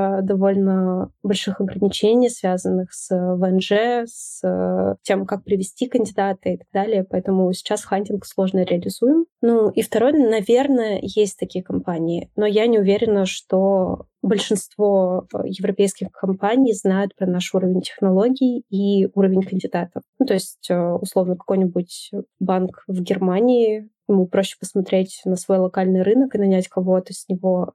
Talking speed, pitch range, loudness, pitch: 135 wpm, 185-210 Hz, -20 LUFS, 195 Hz